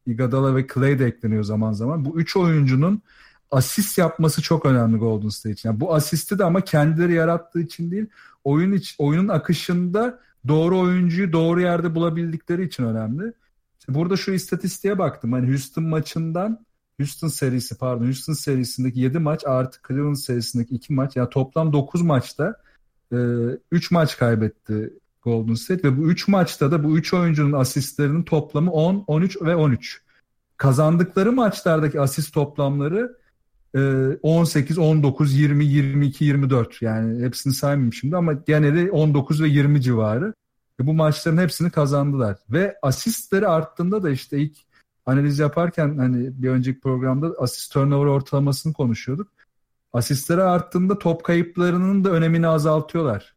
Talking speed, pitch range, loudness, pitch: 145 wpm, 130-170 Hz, -21 LUFS, 150 Hz